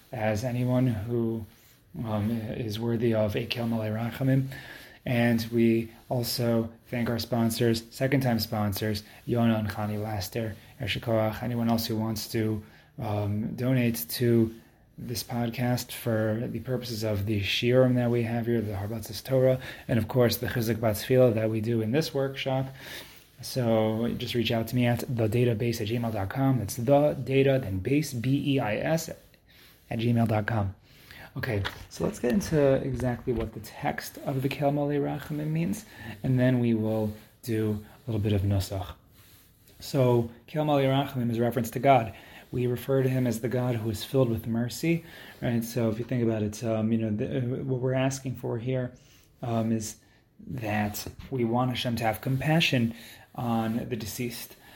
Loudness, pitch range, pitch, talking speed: -28 LUFS, 110-130 Hz, 120 Hz, 165 wpm